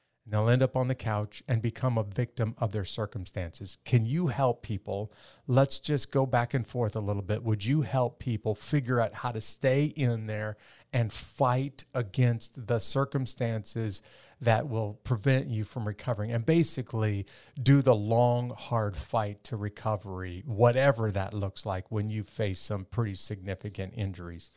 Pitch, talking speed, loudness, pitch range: 115 Hz, 170 wpm, -30 LUFS, 105-130 Hz